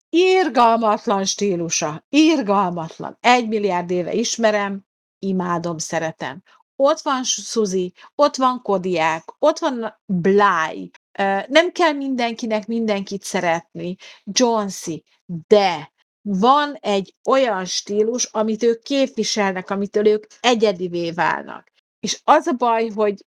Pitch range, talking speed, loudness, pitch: 185-240 Hz, 105 wpm, -19 LUFS, 210 Hz